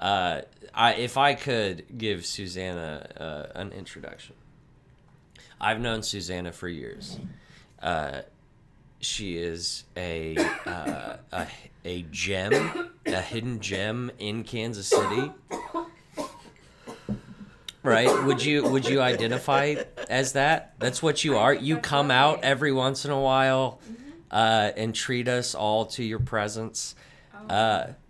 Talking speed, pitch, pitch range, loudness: 125 wpm, 120 Hz, 100-135 Hz, -26 LUFS